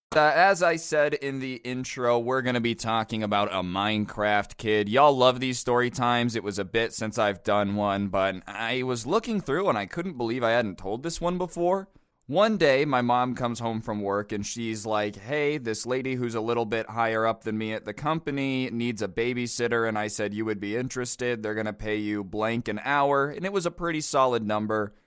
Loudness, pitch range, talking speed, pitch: -26 LUFS, 105-130 Hz, 225 wpm, 120 Hz